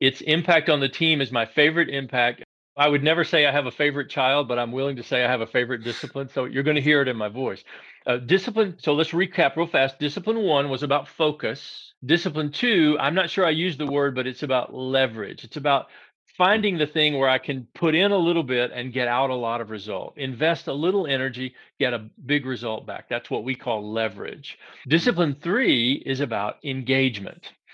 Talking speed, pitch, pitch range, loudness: 220 wpm, 140 Hz, 130-160 Hz, -23 LUFS